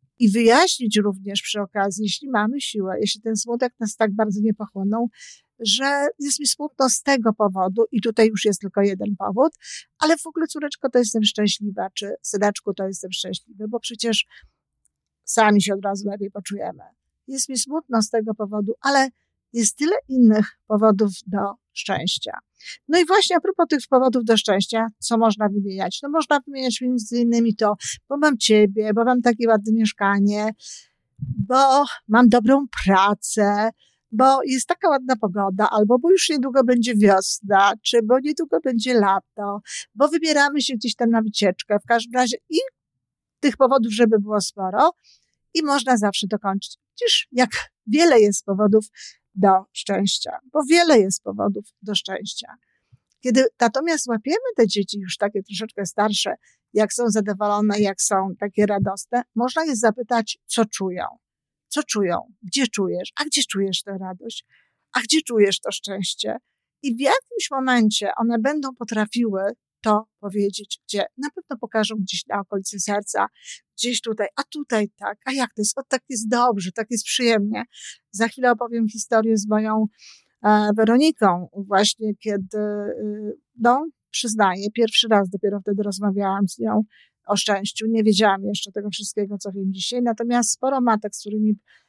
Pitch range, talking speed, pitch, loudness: 205-255 Hz, 160 wpm, 220 Hz, -21 LUFS